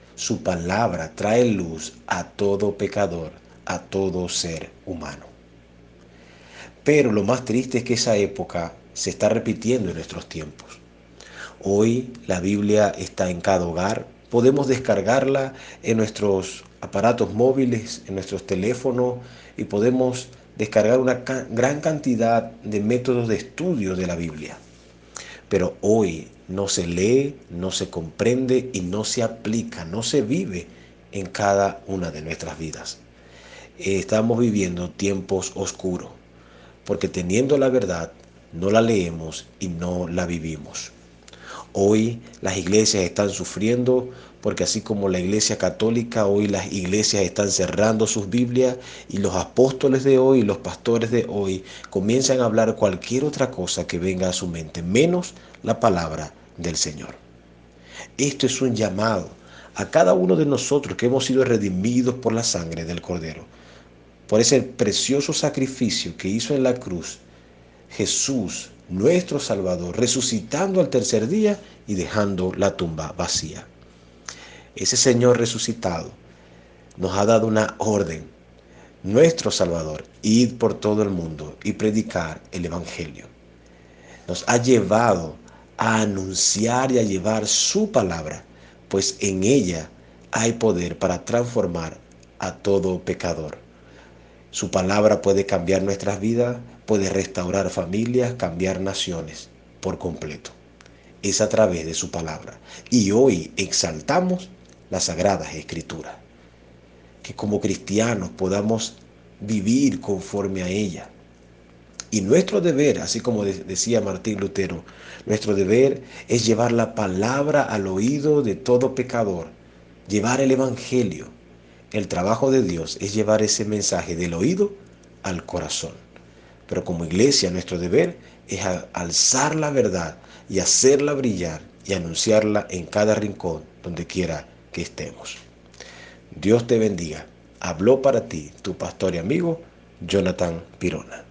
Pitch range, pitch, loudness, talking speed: 80-115 Hz, 100 Hz, -22 LUFS, 130 wpm